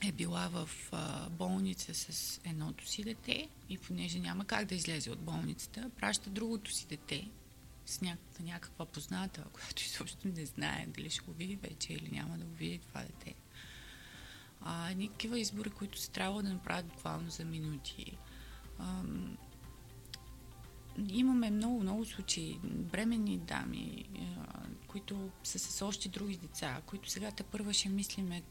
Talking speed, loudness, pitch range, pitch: 145 wpm, -40 LUFS, 160-205 Hz, 190 Hz